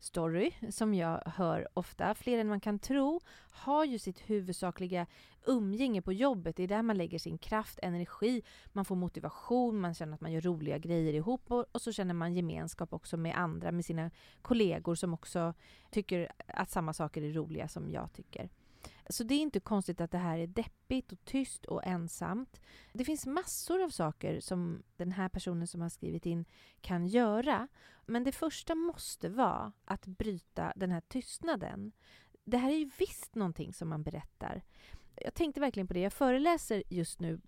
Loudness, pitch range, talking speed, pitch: -36 LUFS, 170-240 Hz, 185 wpm, 185 Hz